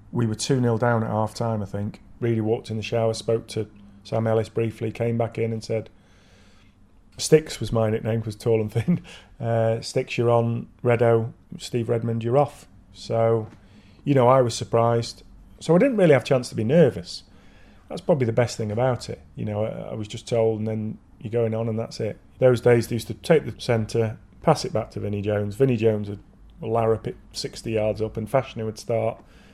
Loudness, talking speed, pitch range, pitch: -24 LUFS, 210 wpm, 110-120 Hz, 115 Hz